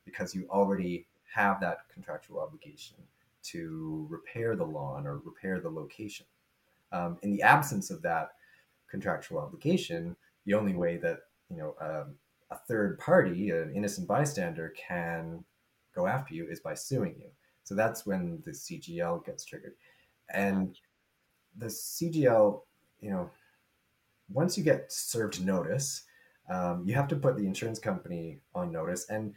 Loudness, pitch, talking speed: -32 LUFS, 105 Hz, 145 wpm